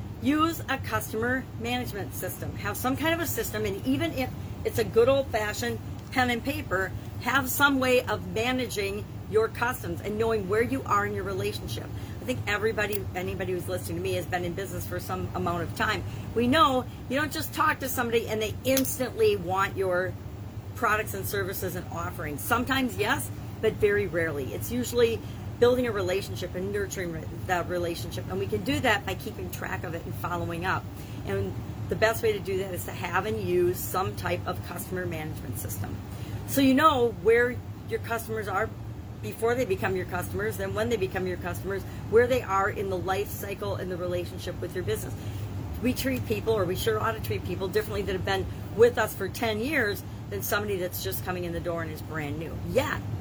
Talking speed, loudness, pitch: 205 wpm, -28 LUFS, 115 Hz